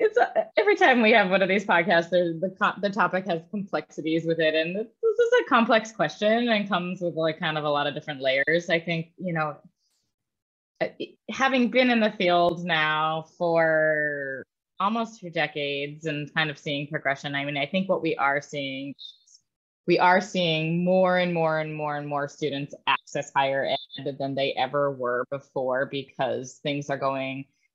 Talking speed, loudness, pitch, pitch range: 180 wpm, -25 LUFS, 160 Hz, 145-185 Hz